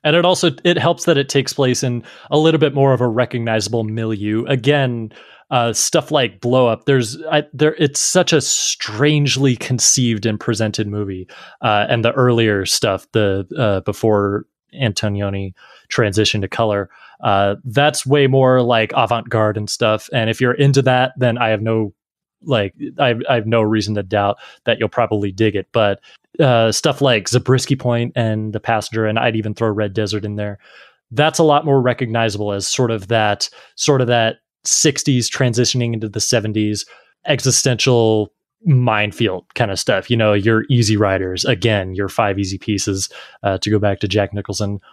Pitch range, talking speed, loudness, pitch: 105-130 Hz, 180 wpm, -17 LUFS, 115 Hz